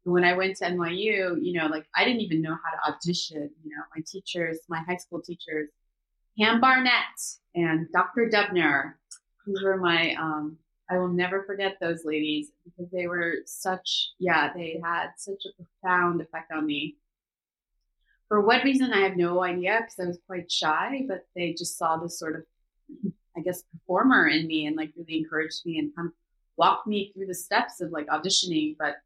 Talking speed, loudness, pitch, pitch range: 190 wpm, -26 LUFS, 175 Hz, 160-190 Hz